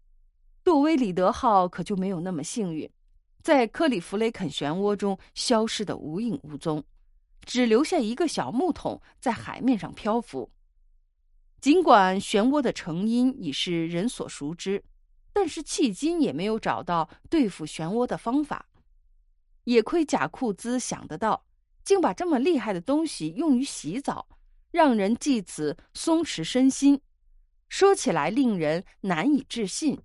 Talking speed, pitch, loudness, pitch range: 220 characters per minute, 220 Hz, -25 LUFS, 175-280 Hz